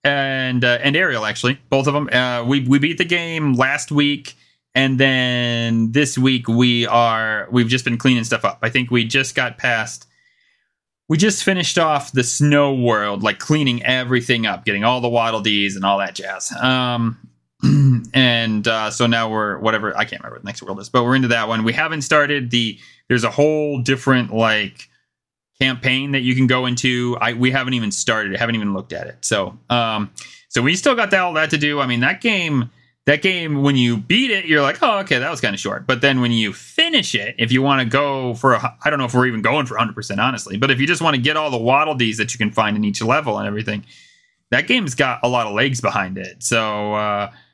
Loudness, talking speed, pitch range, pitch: -17 LUFS, 230 wpm, 115-140 Hz, 125 Hz